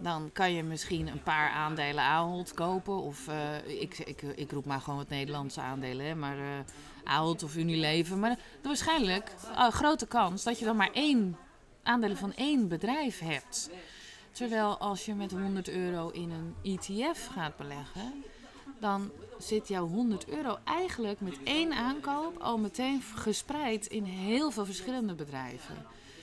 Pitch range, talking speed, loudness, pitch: 155-230 Hz, 160 wpm, -33 LUFS, 190 Hz